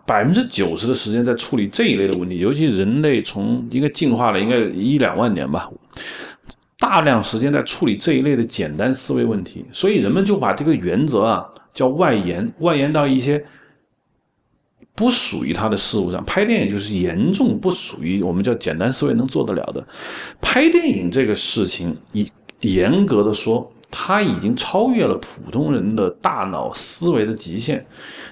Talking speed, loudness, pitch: 275 characters per minute, -18 LUFS, 140 Hz